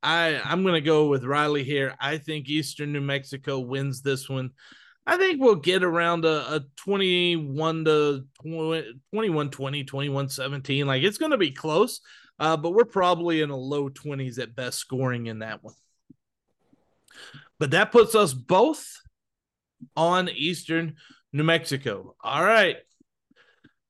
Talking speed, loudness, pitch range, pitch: 155 wpm, -24 LUFS, 135-170 Hz, 150 Hz